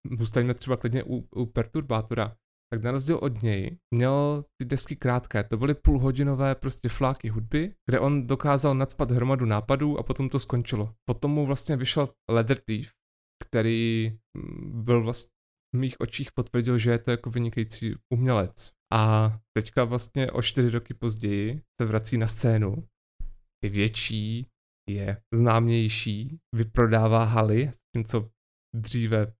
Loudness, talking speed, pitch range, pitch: -27 LUFS, 145 wpm, 110-130 Hz, 120 Hz